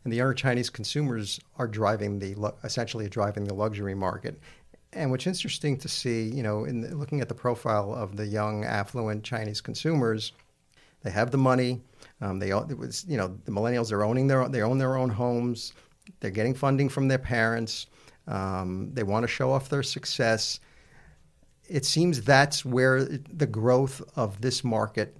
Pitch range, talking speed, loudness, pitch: 105-135 Hz, 170 wpm, -28 LUFS, 120 Hz